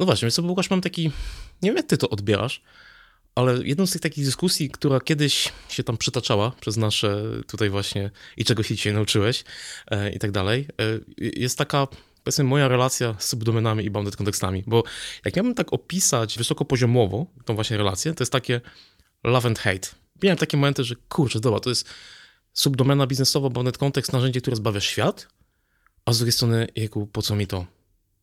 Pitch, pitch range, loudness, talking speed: 120 Hz, 110-140 Hz, -23 LUFS, 185 wpm